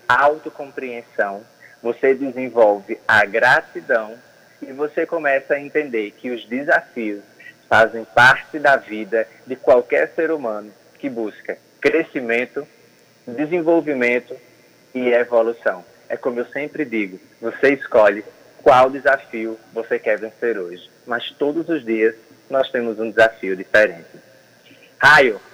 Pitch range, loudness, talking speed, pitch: 115-145 Hz, -18 LUFS, 115 wpm, 120 Hz